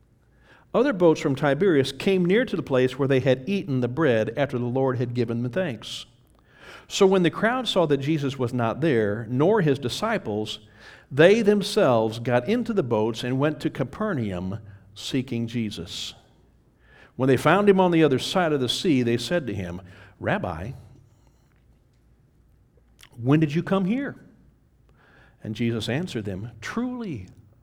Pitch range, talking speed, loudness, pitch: 115-165 Hz, 160 wpm, -23 LUFS, 130 Hz